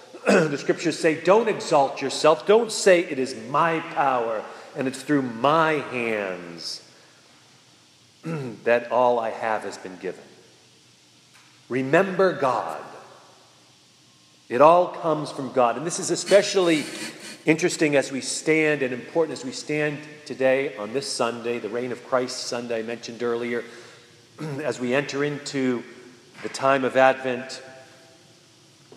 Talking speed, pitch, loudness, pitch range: 135 wpm, 135 Hz, -23 LUFS, 120-155 Hz